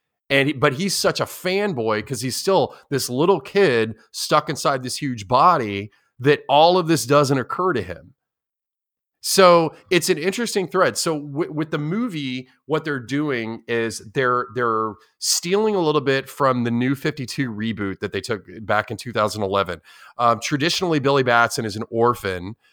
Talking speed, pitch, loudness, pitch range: 165 wpm, 135 Hz, -20 LUFS, 115-160 Hz